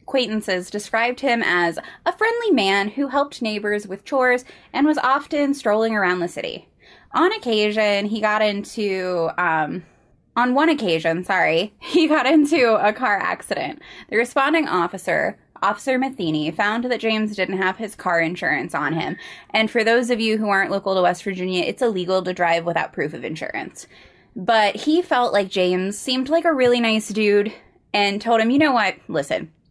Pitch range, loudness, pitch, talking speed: 190-255 Hz, -20 LUFS, 215 Hz, 175 wpm